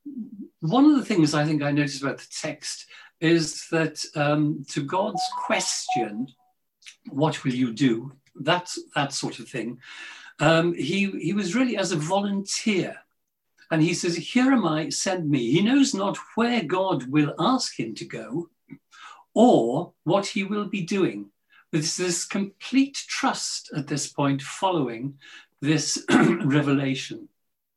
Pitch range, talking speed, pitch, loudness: 150-215 Hz, 145 wpm, 175 Hz, -24 LUFS